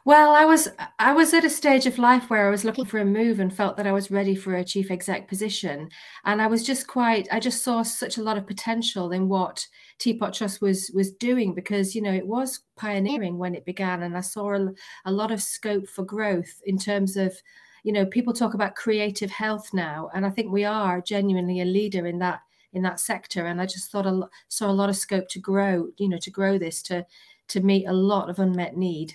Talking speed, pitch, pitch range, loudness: 240 wpm, 200 Hz, 185-220 Hz, -24 LUFS